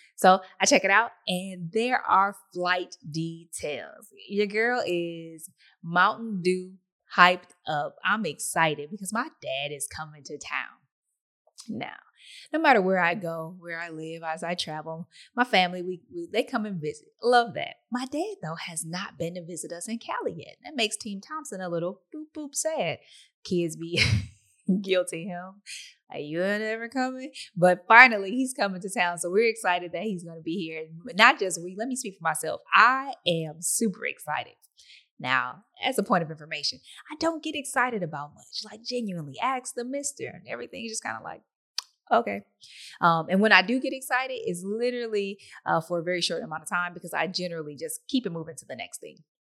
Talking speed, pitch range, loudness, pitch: 195 wpm, 170-240 Hz, -26 LUFS, 185 Hz